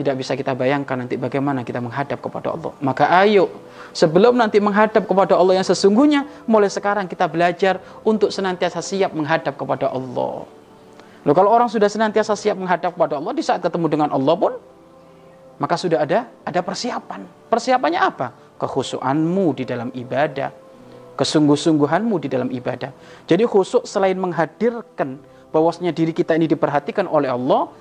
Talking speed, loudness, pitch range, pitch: 150 wpm, -19 LUFS, 140-200 Hz, 175 Hz